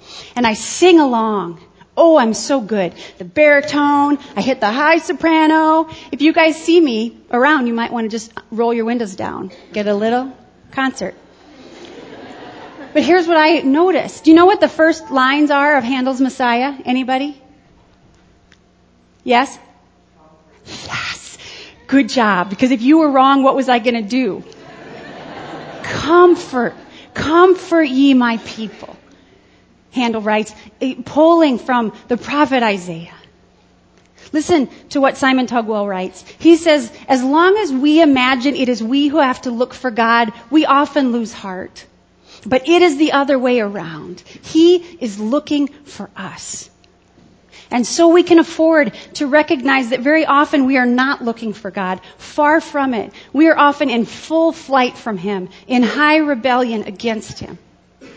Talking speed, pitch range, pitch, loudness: 155 wpm, 235-305 Hz, 265 Hz, -14 LUFS